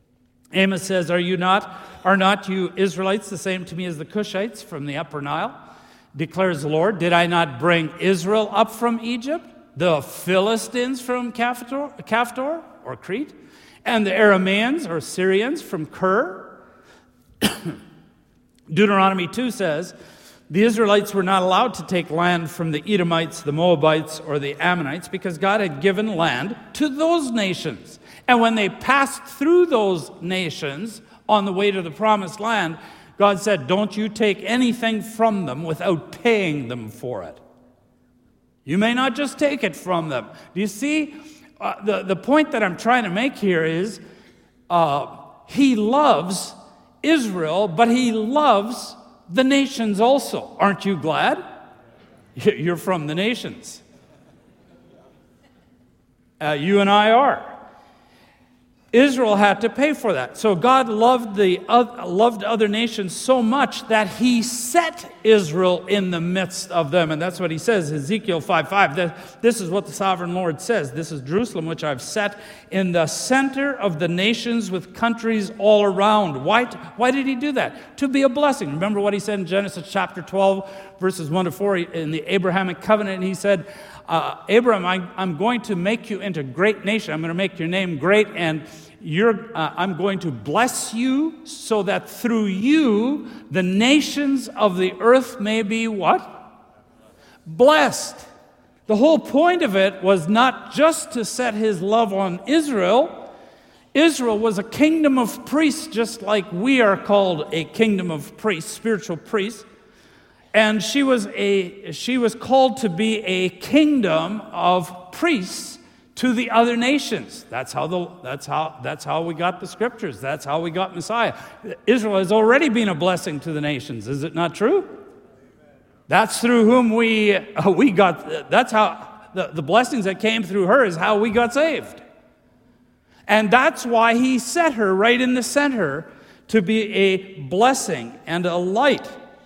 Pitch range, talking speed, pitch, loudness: 180-235 Hz, 165 wpm, 205 Hz, -20 LUFS